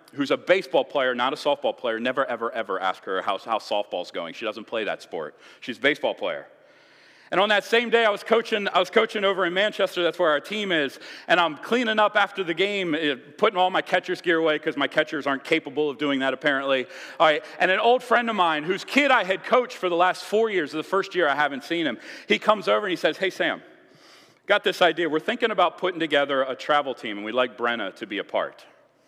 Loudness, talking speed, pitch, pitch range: -23 LUFS, 245 wpm, 180 Hz, 150-210 Hz